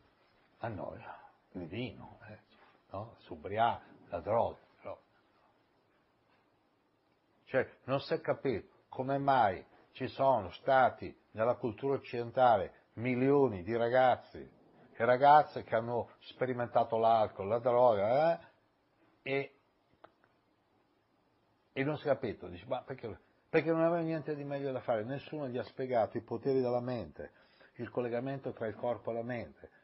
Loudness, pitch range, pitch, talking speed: -33 LUFS, 120-140 Hz, 130 Hz, 135 wpm